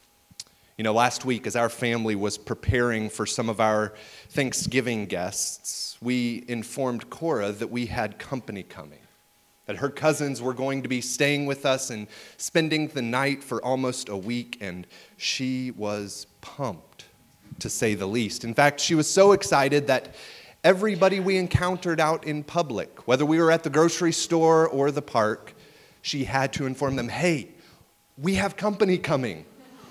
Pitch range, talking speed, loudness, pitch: 115-155 Hz, 165 wpm, -25 LUFS, 130 Hz